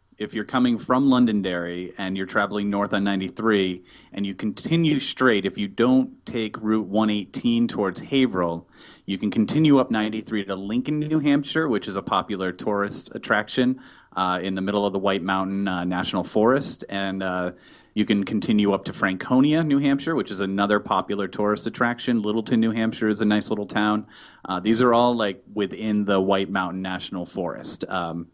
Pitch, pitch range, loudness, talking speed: 105 Hz, 95-120 Hz, -23 LUFS, 180 wpm